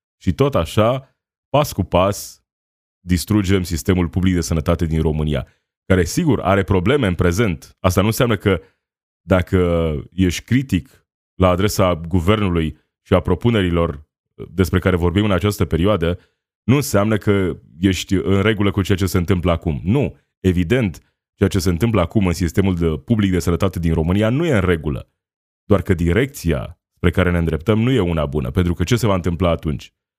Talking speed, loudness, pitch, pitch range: 170 wpm, -18 LUFS, 95 Hz, 85-100 Hz